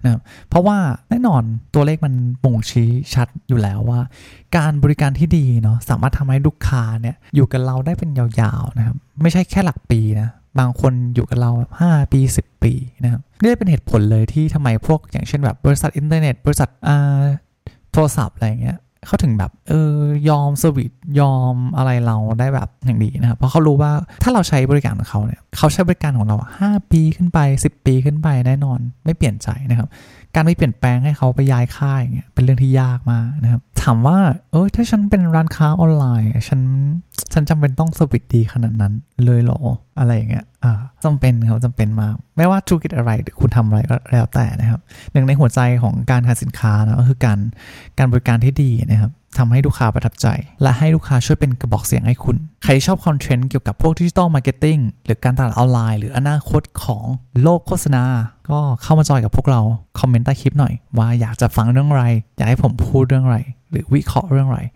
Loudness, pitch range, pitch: -16 LUFS, 120-145 Hz, 130 Hz